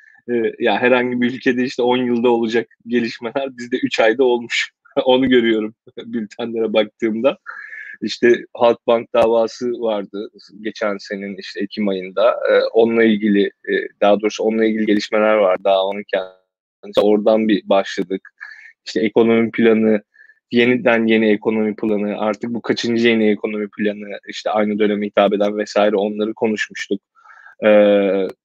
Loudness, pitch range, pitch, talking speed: -17 LUFS, 105-120 Hz, 110 Hz, 130 wpm